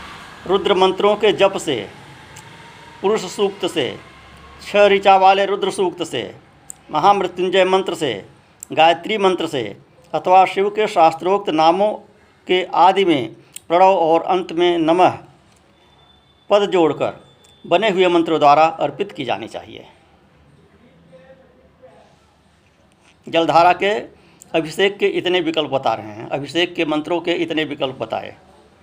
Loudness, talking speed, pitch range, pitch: -17 LUFS, 125 wpm, 160-200 Hz, 180 Hz